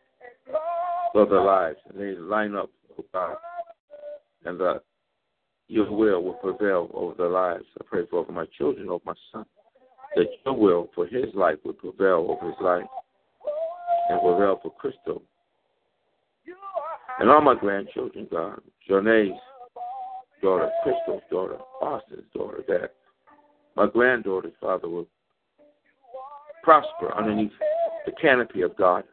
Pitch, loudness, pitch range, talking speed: 325 Hz, -24 LUFS, 255-395 Hz, 130 wpm